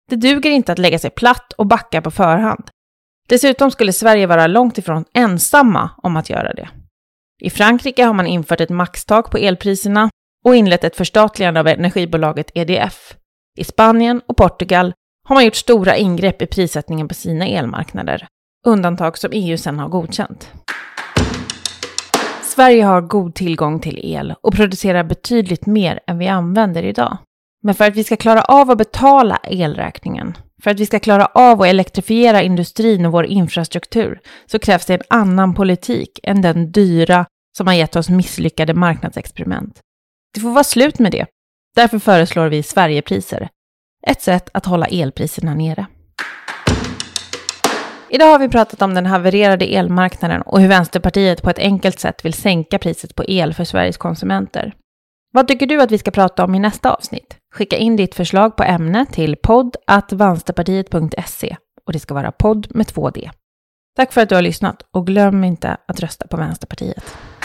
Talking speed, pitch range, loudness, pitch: 165 wpm, 170-220 Hz, -14 LUFS, 190 Hz